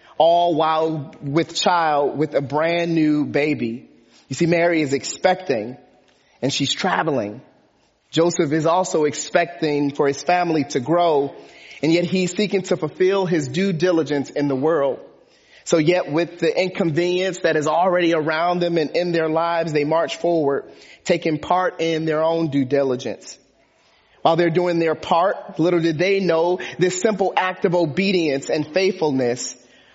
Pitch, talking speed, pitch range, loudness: 165 Hz, 155 wpm, 155-180 Hz, -20 LUFS